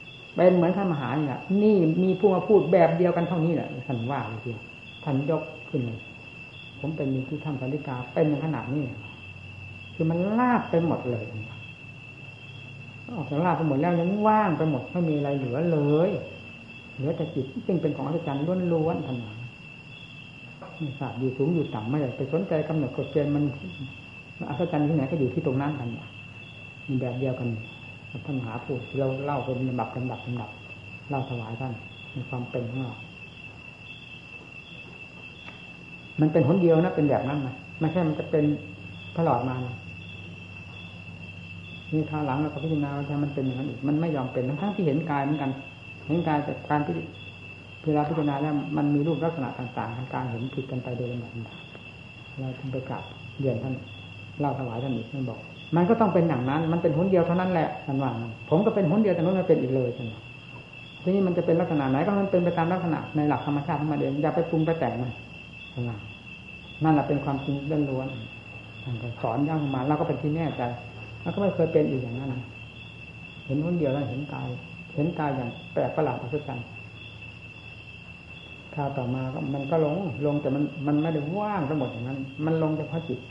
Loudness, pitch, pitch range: -27 LUFS, 140 Hz, 125-155 Hz